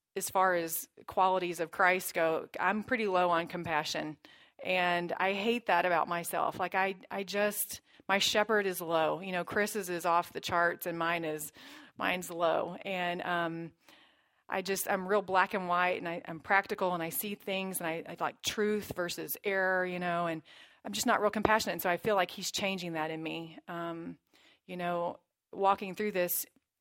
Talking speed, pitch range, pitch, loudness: 190 wpm, 170-195 Hz, 180 Hz, -32 LUFS